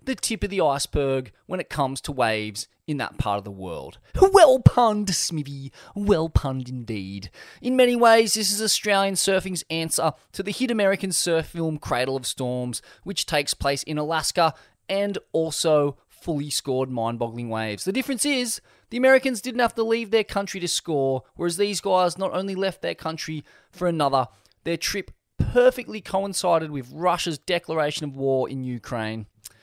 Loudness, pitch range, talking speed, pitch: -23 LUFS, 135-200 Hz, 170 wpm, 160 Hz